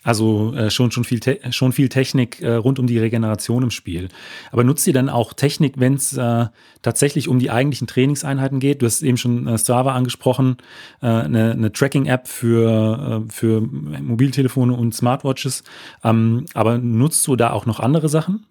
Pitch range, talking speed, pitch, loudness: 115-135 Hz, 185 wpm, 125 Hz, -18 LUFS